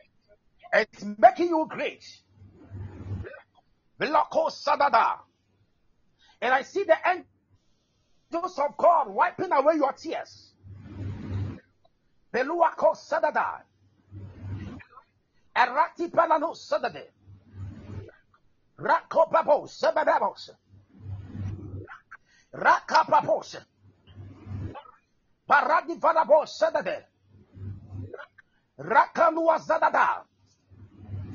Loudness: -25 LUFS